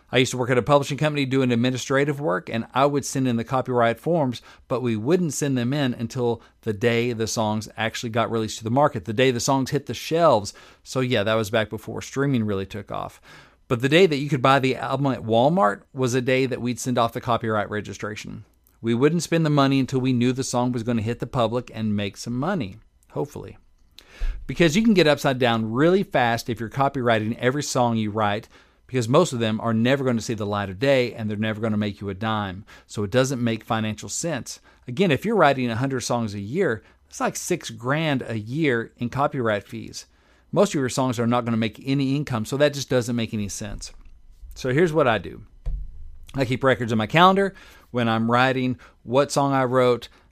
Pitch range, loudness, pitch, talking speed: 110-135 Hz, -23 LUFS, 120 Hz, 230 wpm